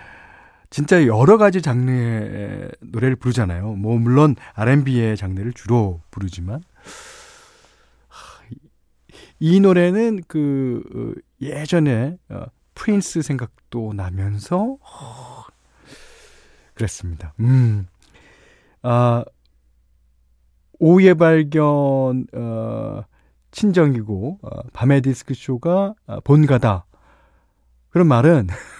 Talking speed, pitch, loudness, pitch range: 165 characters per minute, 125 Hz, -18 LUFS, 100-160 Hz